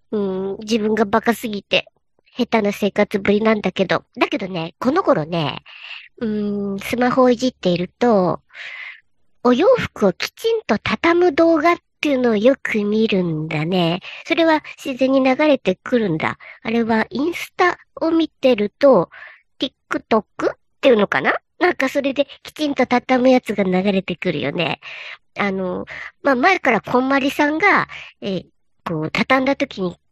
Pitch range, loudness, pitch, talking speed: 200-280 Hz, -18 LUFS, 240 Hz, 295 characters per minute